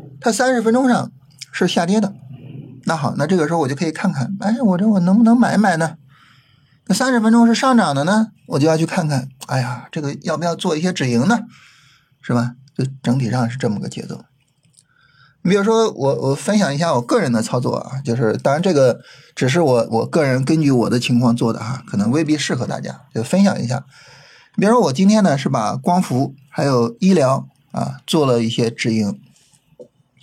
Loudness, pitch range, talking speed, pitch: -17 LUFS, 130-190 Hz, 295 characters per minute, 145 Hz